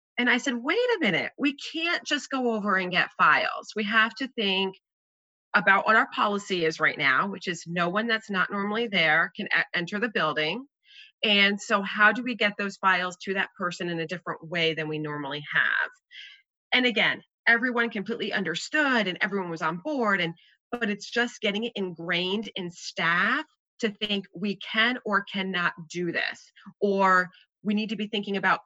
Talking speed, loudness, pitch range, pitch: 190 wpm, -25 LUFS, 180-235 Hz, 205 Hz